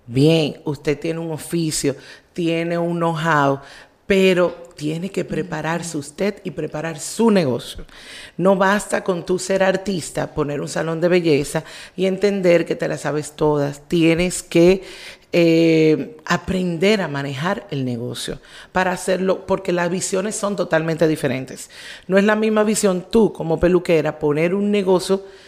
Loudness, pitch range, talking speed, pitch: -19 LUFS, 155-190 Hz, 145 wpm, 170 Hz